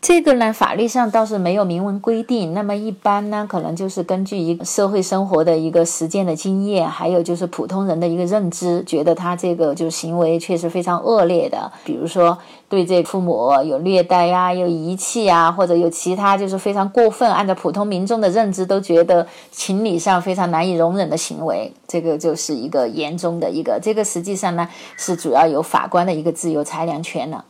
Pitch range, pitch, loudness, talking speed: 170-200 Hz, 180 Hz, -18 LUFS, 325 characters per minute